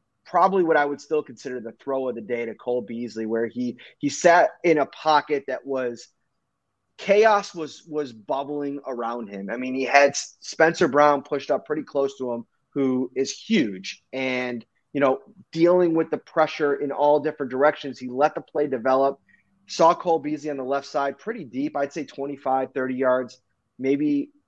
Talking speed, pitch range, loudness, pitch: 180 wpm, 130-155 Hz, -23 LUFS, 140 Hz